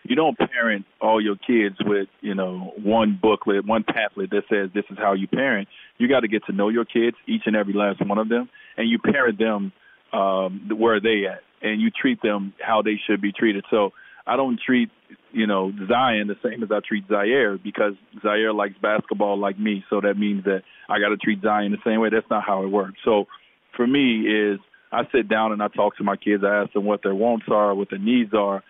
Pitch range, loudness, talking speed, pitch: 100-110 Hz, -22 LUFS, 235 wpm, 105 Hz